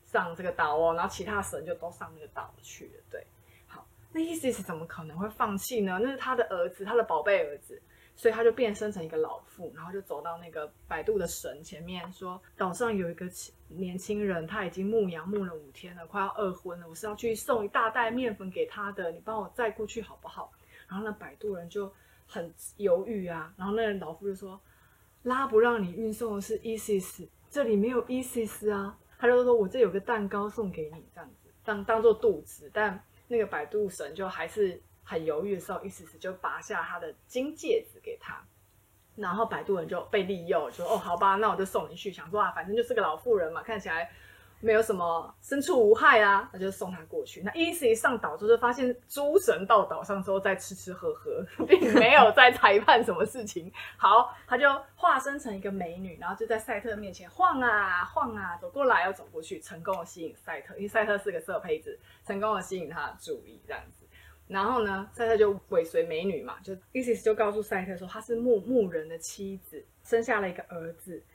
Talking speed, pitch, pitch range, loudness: 315 characters per minute, 210 Hz, 190-245 Hz, -28 LUFS